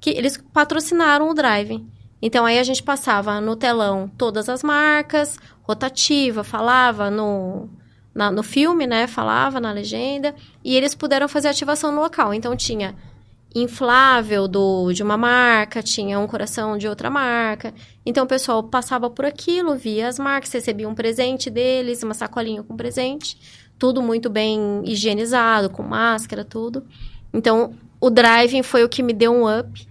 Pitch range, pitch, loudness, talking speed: 215-265 Hz, 240 Hz, -19 LUFS, 160 wpm